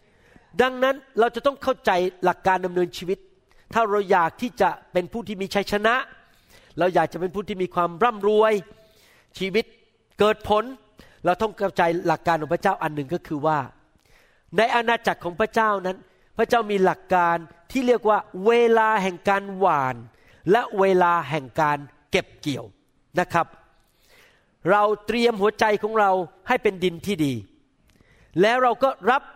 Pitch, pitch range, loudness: 195 Hz, 170-220 Hz, -22 LUFS